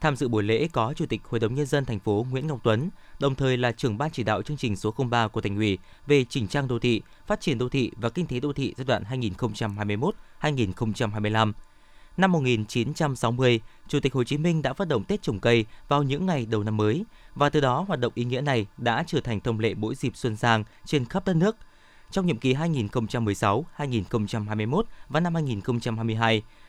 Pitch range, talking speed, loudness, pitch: 110-145 Hz, 210 wpm, -26 LUFS, 125 Hz